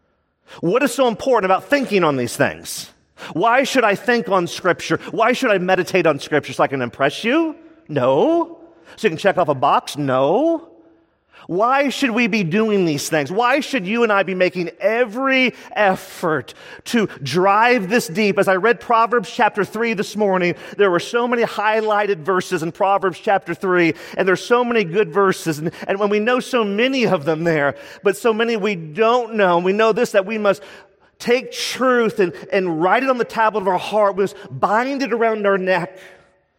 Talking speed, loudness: 195 wpm, -18 LUFS